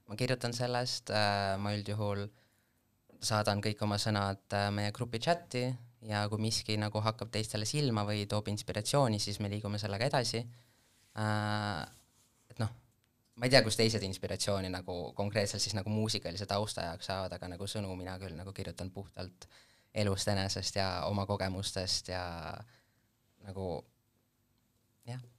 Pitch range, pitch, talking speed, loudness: 100-115 Hz, 105 Hz, 145 wpm, -34 LUFS